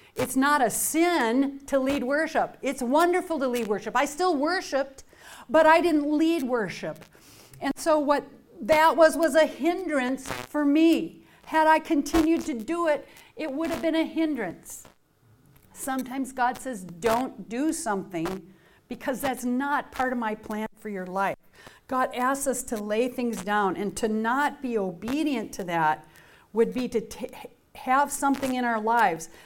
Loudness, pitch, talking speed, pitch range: -25 LUFS, 265 Hz, 165 wpm, 225-310 Hz